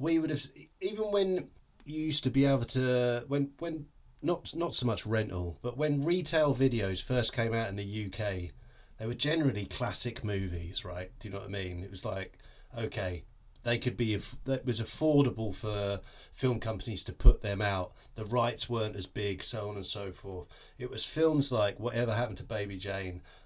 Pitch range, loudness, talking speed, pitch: 100-135 Hz, -32 LUFS, 195 wpm, 115 Hz